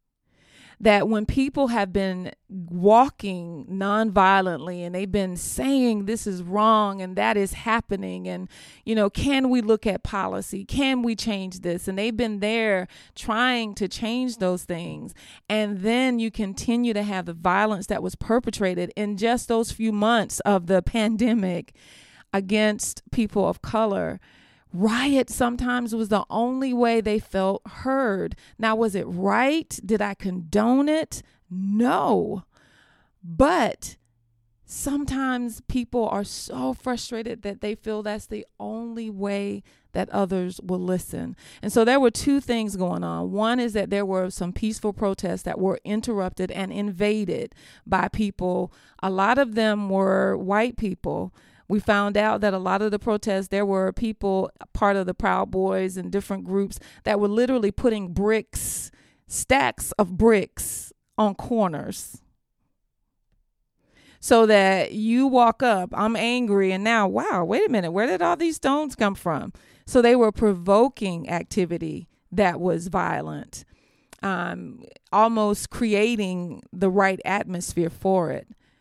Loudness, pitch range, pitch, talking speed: -23 LUFS, 190-230 Hz, 205 Hz, 145 wpm